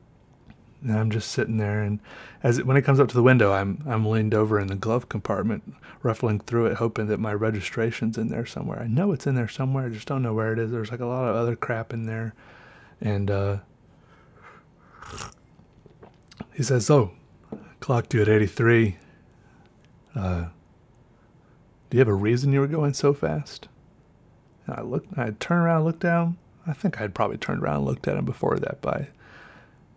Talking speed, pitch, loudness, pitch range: 195 wpm, 115 Hz, -25 LUFS, 105-130 Hz